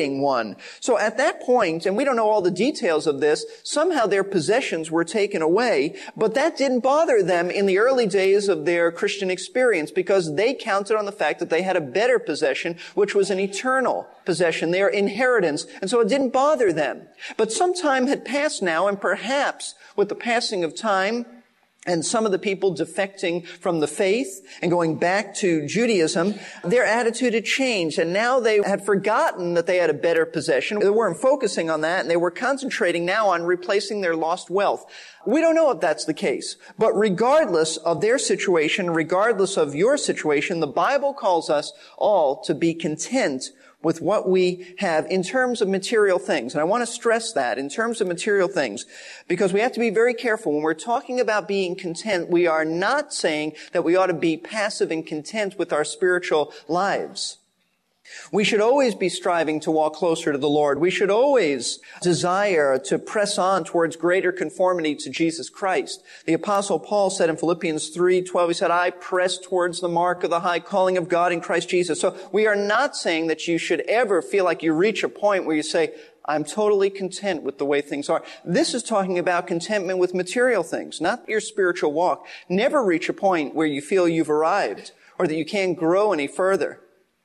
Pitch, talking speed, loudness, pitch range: 190 Hz, 200 wpm, -22 LUFS, 170-225 Hz